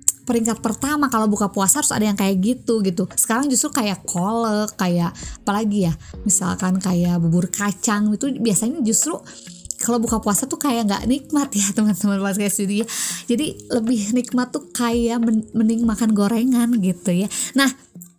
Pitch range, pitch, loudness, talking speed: 200-240 Hz, 220 Hz, -20 LUFS, 150 wpm